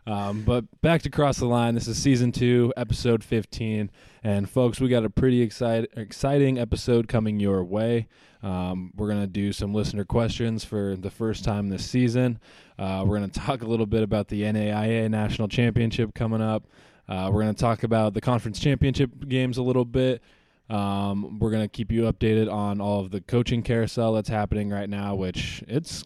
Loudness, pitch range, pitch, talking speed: -25 LUFS, 105-120 Hz, 110 Hz, 200 wpm